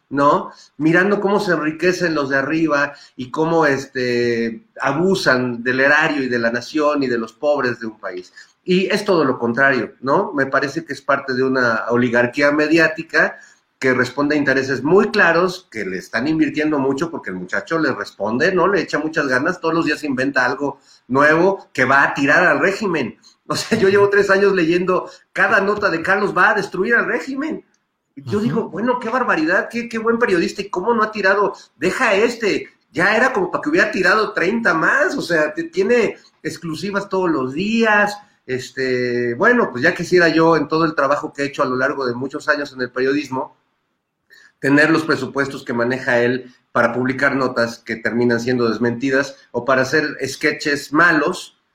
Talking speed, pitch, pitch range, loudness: 190 wpm, 150 Hz, 130-190 Hz, -17 LUFS